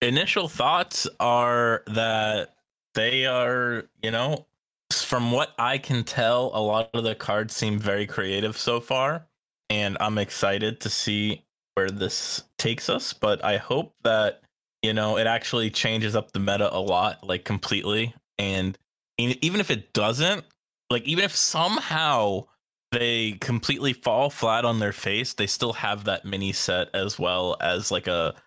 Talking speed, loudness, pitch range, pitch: 160 wpm, -25 LUFS, 105-125 Hz, 110 Hz